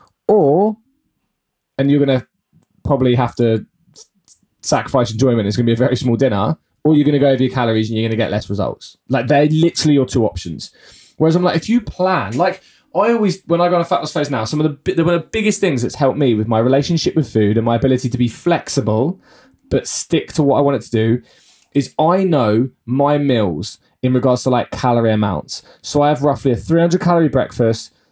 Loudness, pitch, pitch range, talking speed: -16 LUFS, 135 Hz, 115-155 Hz, 225 wpm